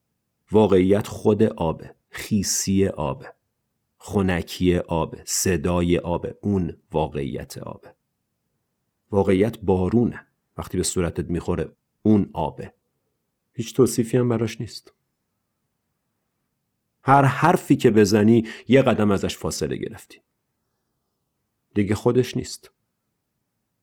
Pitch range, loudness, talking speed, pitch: 90-115 Hz, -22 LUFS, 95 wpm, 100 Hz